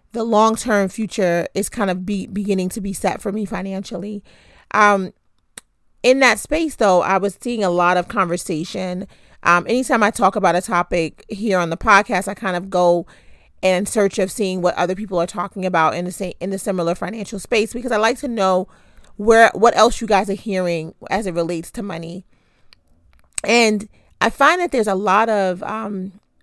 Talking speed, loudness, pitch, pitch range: 195 wpm, -18 LUFS, 195 Hz, 180-215 Hz